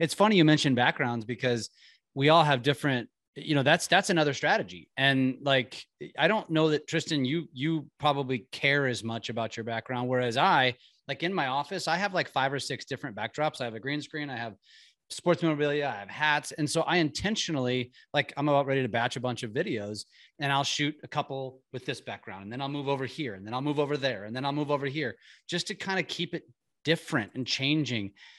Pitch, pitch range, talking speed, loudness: 140 Hz, 125-155 Hz, 225 wpm, -28 LUFS